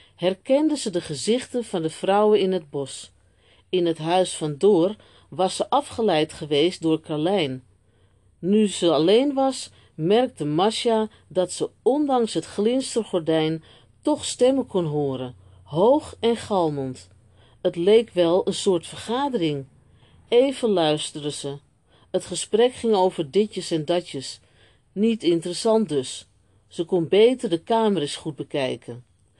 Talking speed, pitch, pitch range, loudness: 135 wpm, 175 Hz, 145-215 Hz, -23 LUFS